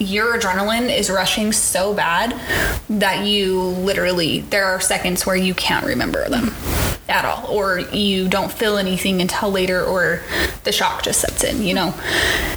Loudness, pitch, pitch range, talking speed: -18 LUFS, 195 Hz, 185-205 Hz, 160 wpm